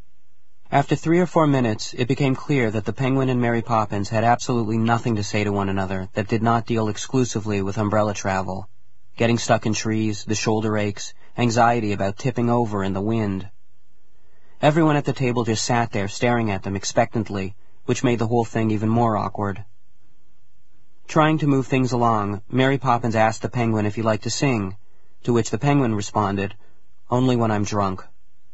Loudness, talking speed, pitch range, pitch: -22 LUFS, 185 wpm, 105-120 Hz, 110 Hz